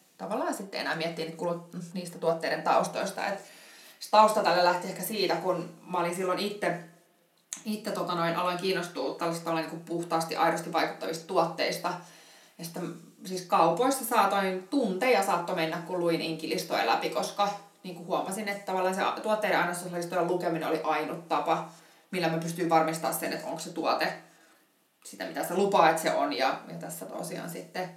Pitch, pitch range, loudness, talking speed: 175 Hz, 165-185 Hz, -29 LUFS, 160 wpm